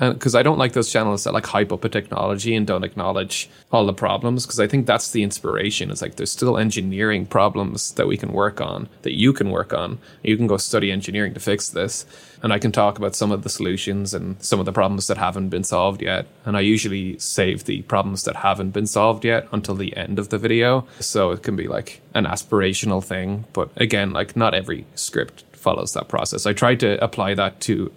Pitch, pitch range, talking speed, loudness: 105 Hz, 95-115 Hz, 230 wpm, -21 LUFS